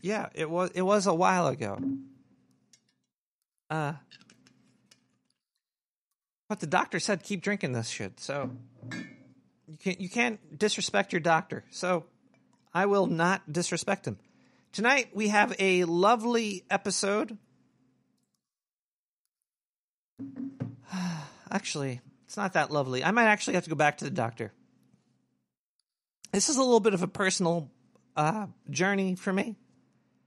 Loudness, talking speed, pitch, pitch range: -28 LUFS, 125 wpm, 185 Hz, 150-205 Hz